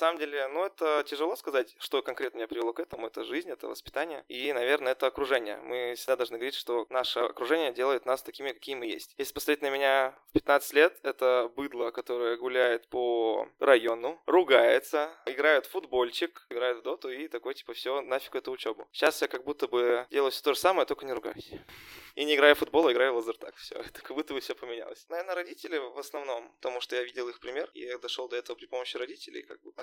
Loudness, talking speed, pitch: -30 LUFS, 220 wpm, 140 Hz